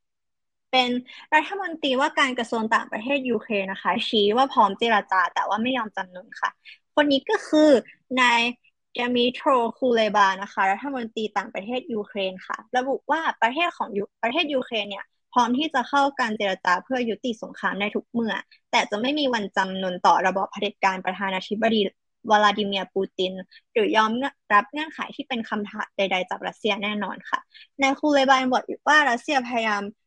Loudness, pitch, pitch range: -23 LUFS, 230 Hz, 200-265 Hz